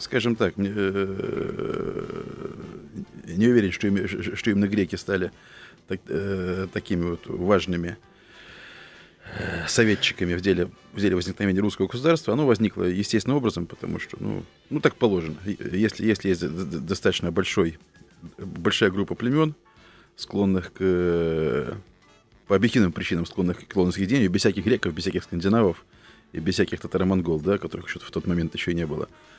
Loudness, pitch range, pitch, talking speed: -25 LUFS, 90-105 Hz, 95 Hz, 145 wpm